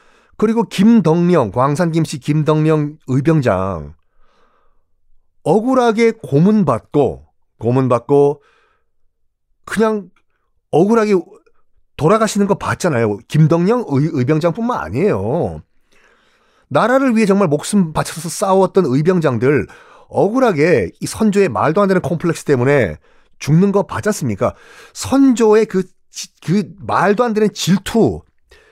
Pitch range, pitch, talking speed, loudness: 140-210 Hz, 175 Hz, 240 characters per minute, -15 LUFS